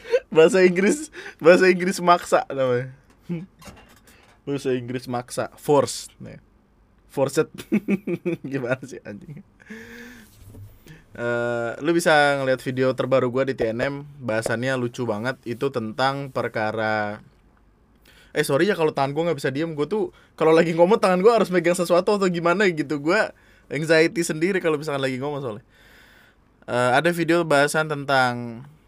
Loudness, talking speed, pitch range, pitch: -22 LUFS, 135 wpm, 125-170 Hz, 140 Hz